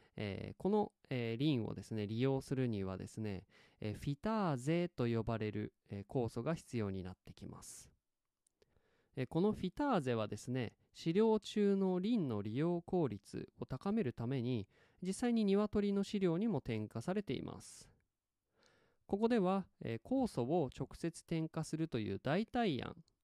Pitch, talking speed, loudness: 140 Hz, 275 characters per minute, -39 LUFS